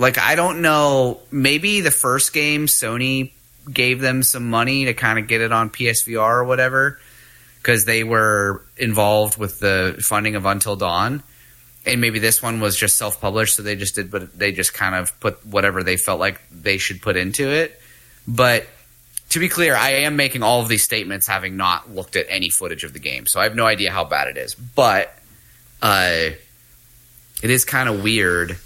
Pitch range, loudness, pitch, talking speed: 105-130 Hz, -18 LUFS, 115 Hz, 200 wpm